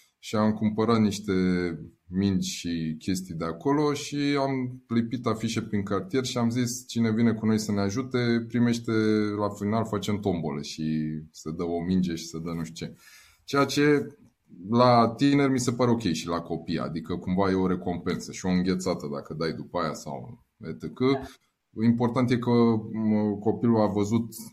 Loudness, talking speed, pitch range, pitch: -26 LUFS, 175 wpm, 90-120 Hz, 105 Hz